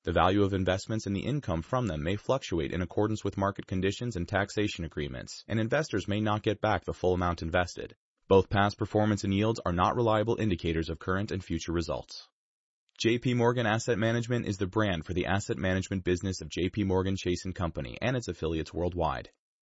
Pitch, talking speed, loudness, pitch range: 100 Hz, 195 wpm, -30 LUFS, 90-110 Hz